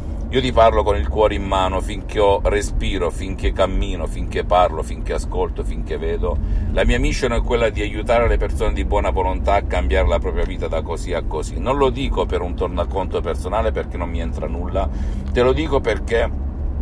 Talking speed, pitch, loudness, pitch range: 200 wpm, 90 Hz, -20 LUFS, 75-100 Hz